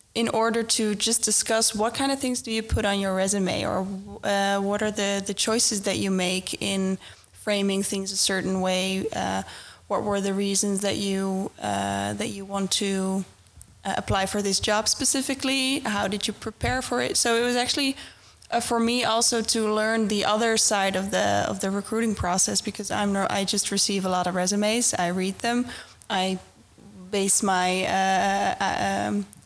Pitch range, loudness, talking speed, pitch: 190-225 Hz, -24 LUFS, 190 wpm, 200 Hz